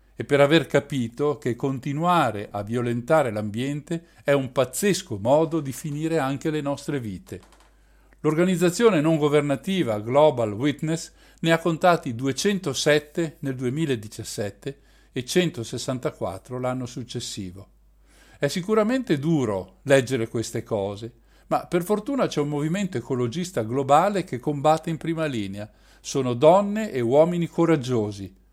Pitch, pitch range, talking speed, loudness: 140 Hz, 120-165 Hz, 120 wpm, -24 LUFS